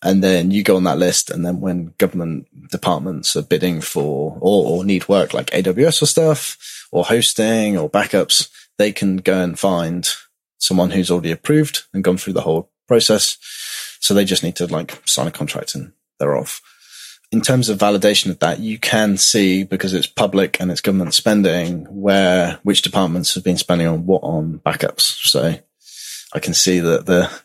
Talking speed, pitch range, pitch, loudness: 190 wpm, 90-105 Hz, 95 Hz, -17 LUFS